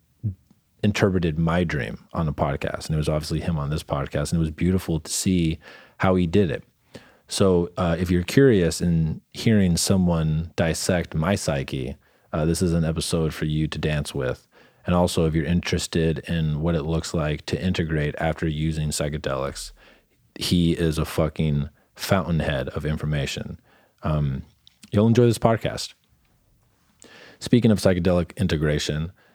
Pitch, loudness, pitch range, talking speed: 85 Hz, -23 LUFS, 75-90 Hz, 155 wpm